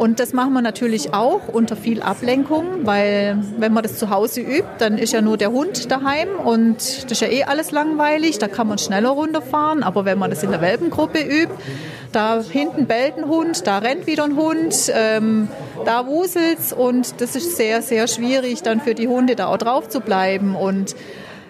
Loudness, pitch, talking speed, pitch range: -19 LUFS, 240 Hz, 200 wpm, 220-295 Hz